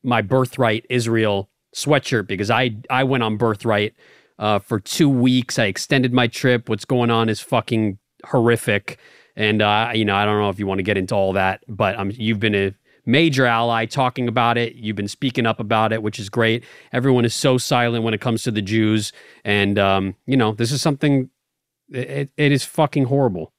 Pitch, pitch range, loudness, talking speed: 115 Hz, 105-125 Hz, -19 LUFS, 205 wpm